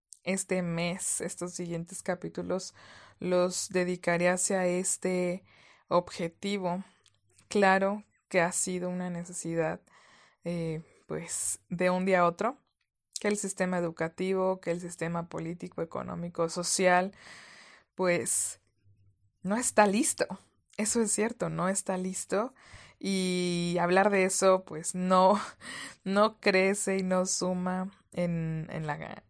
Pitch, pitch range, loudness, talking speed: 180 Hz, 170-190 Hz, -30 LUFS, 115 wpm